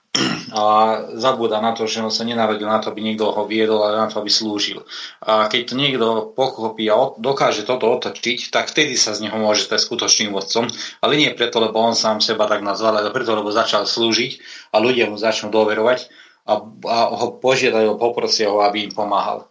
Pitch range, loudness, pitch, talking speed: 105-115 Hz, -18 LUFS, 110 Hz, 195 wpm